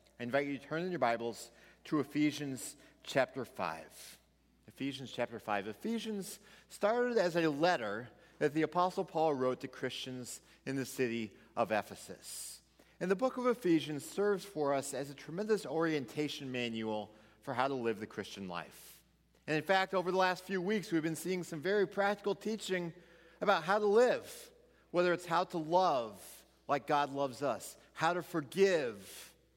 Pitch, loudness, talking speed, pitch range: 160 Hz, -35 LUFS, 170 wpm, 135-190 Hz